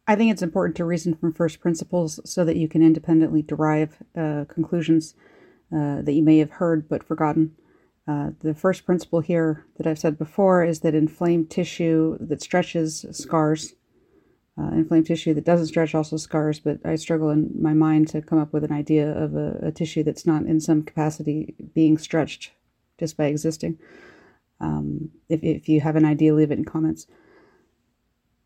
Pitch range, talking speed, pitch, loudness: 155-165 Hz, 180 wpm, 160 Hz, -22 LUFS